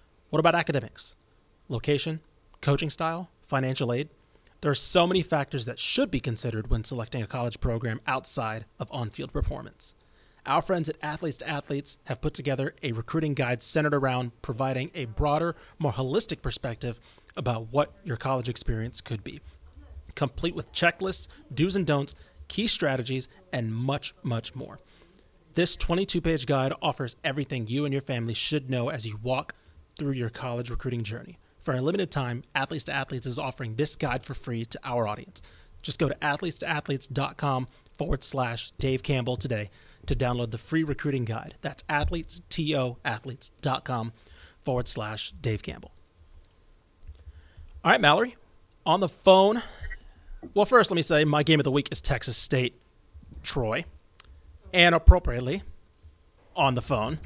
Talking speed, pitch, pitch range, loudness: 160 wpm, 130 Hz, 115-150 Hz, -28 LUFS